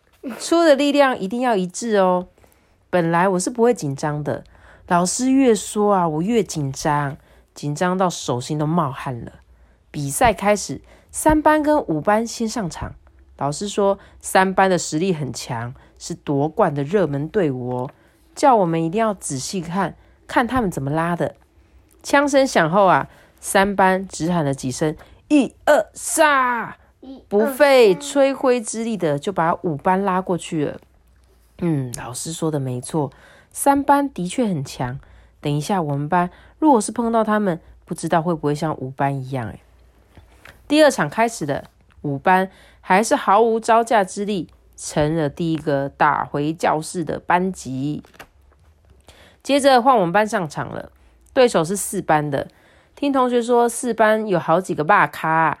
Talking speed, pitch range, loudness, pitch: 225 characters per minute, 145-225 Hz, -19 LUFS, 175 Hz